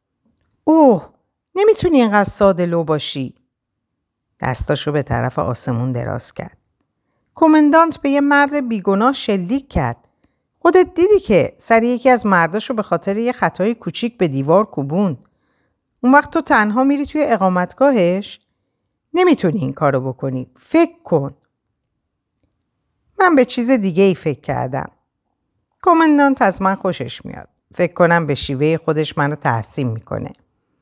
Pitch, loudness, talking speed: 195 Hz, -16 LUFS, 130 wpm